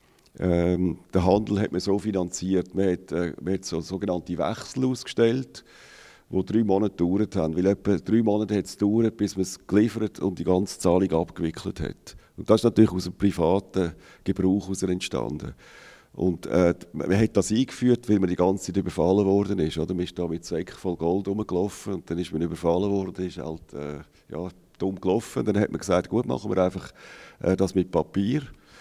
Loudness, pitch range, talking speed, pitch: -25 LUFS, 90-100 Hz, 195 wpm, 95 Hz